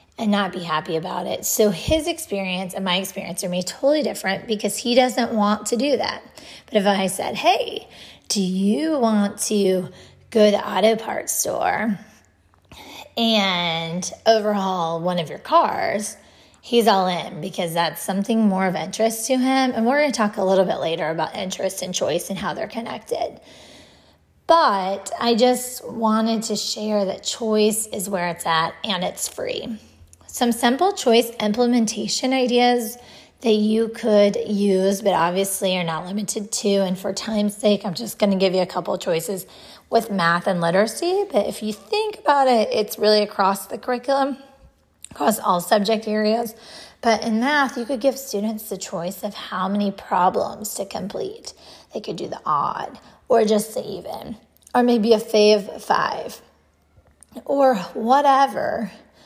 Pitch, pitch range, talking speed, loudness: 215 Hz, 195-240 Hz, 165 wpm, -21 LUFS